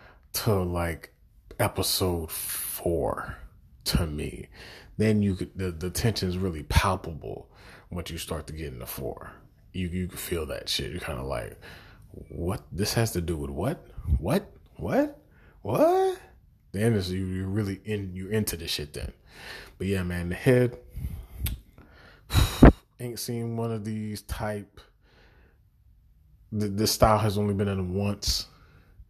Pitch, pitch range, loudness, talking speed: 95 Hz, 85-105 Hz, -28 LUFS, 150 wpm